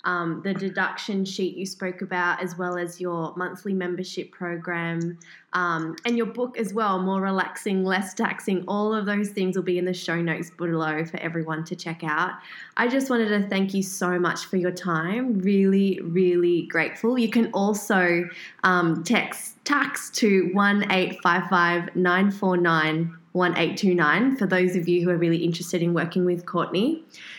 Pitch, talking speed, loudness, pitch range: 180 Hz, 160 wpm, -24 LUFS, 175-195 Hz